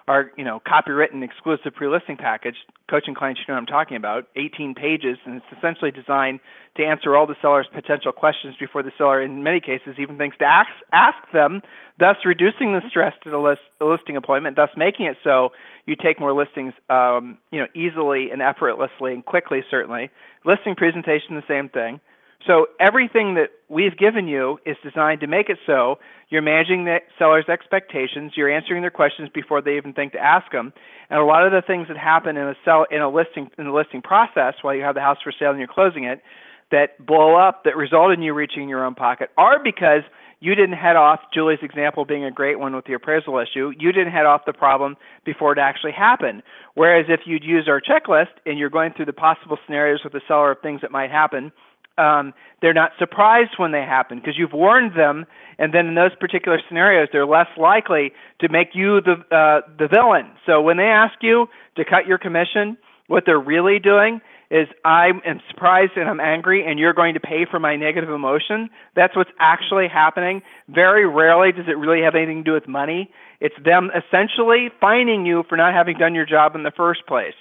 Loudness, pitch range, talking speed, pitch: -18 LUFS, 145-175 Hz, 210 wpm, 155 Hz